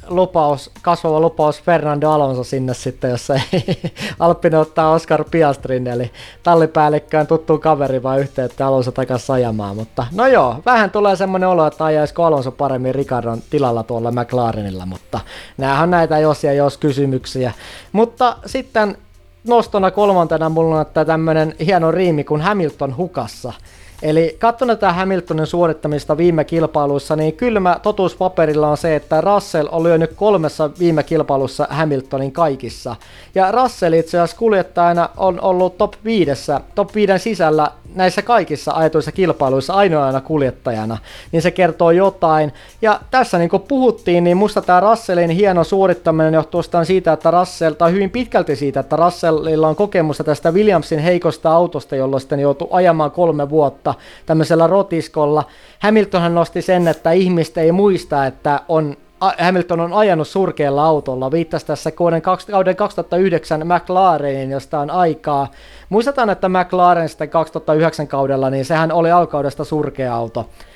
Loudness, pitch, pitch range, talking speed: -16 LUFS, 160 Hz, 145-180 Hz, 145 wpm